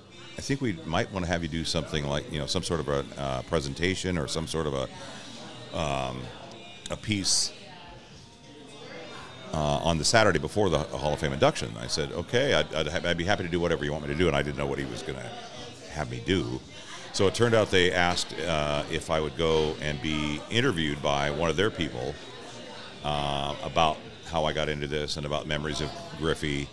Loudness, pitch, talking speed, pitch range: -28 LUFS, 75 Hz, 215 wpm, 75-85 Hz